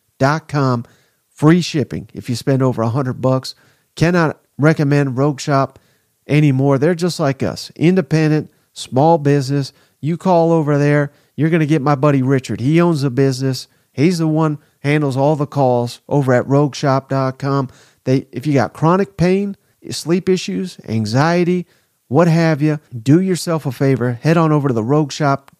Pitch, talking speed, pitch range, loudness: 145 Hz, 165 wpm, 135-160 Hz, -16 LUFS